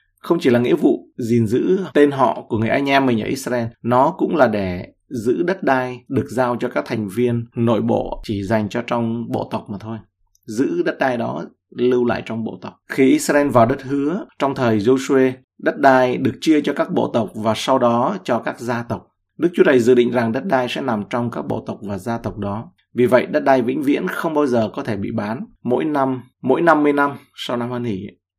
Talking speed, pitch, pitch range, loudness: 235 wpm, 125 Hz, 115-135 Hz, -19 LUFS